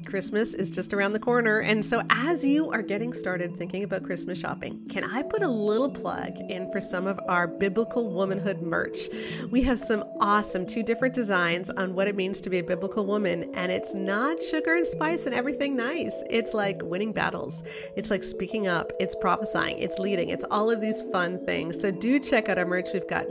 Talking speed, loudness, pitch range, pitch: 210 wpm, -27 LUFS, 180-225 Hz, 200 Hz